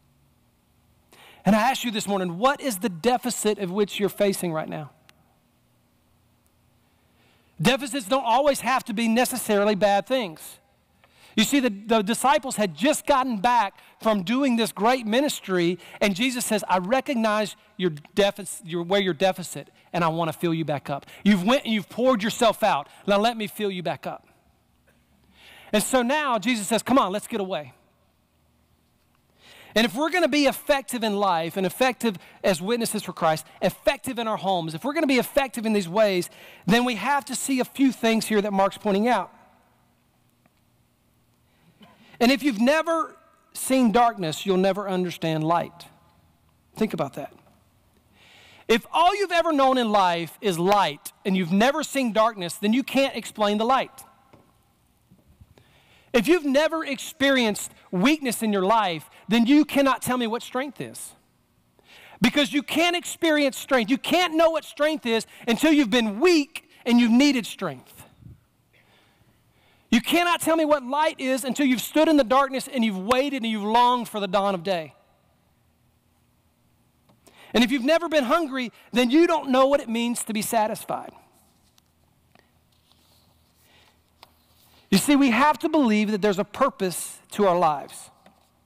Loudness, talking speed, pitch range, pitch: -23 LUFS, 165 wpm, 195-270 Hz, 230 Hz